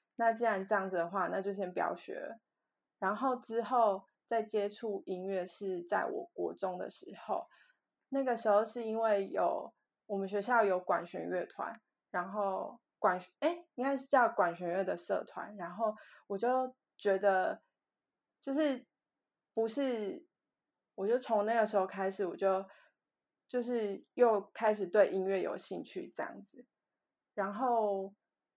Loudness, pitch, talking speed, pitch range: -35 LUFS, 210 Hz, 210 characters per minute, 195-240 Hz